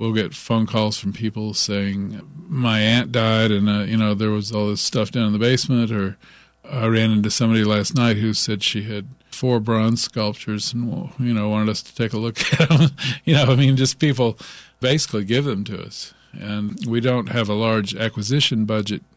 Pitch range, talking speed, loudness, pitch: 105-125 Hz, 215 wpm, -20 LUFS, 110 Hz